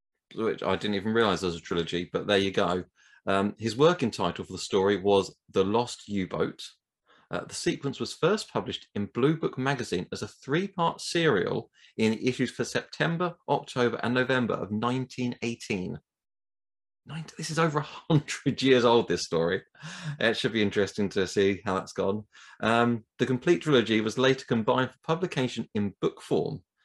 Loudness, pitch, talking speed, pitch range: -28 LUFS, 120 Hz, 170 wpm, 100-130 Hz